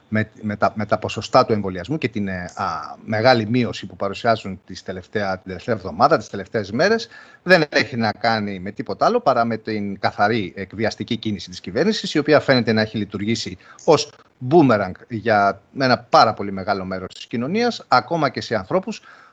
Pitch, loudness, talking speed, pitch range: 110 Hz, -20 LUFS, 180 wpm, 100-125 Hz